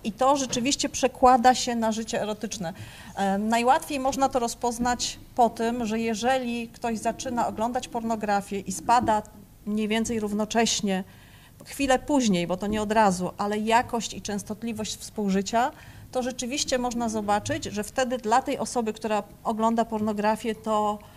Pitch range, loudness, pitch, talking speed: 210-245 Hz, -26 LUFS, 230 Hz, 140 wpm